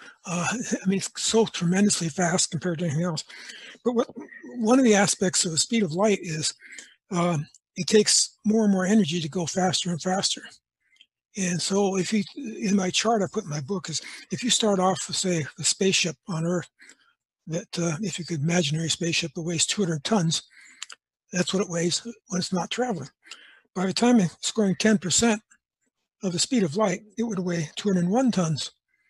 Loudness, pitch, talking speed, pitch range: -24 LUFS, 185 Hz, 190 wpm, 170-215 Hz